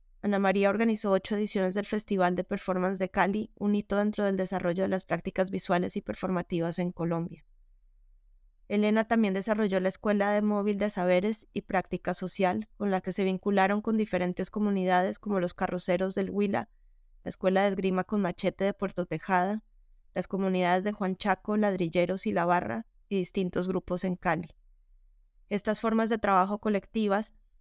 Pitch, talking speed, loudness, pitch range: 190 Hz, 165 wpm, -29 LUFS, 180-205 Hz